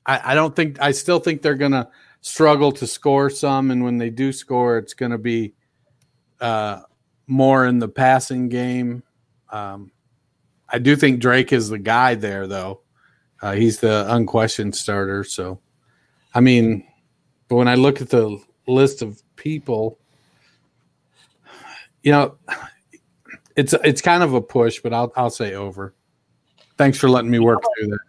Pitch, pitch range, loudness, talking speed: 125 Hz, 110-135 Hz, -18 LUFS, 160 wpm